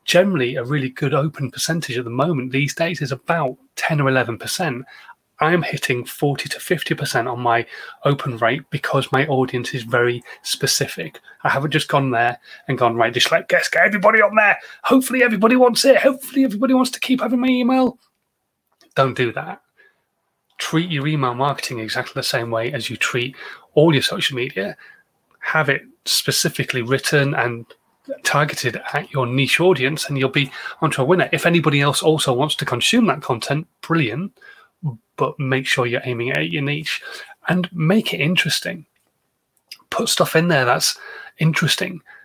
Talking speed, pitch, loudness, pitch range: 170 wpm, 150 Hz, -19 LUFS, 130-185 Hz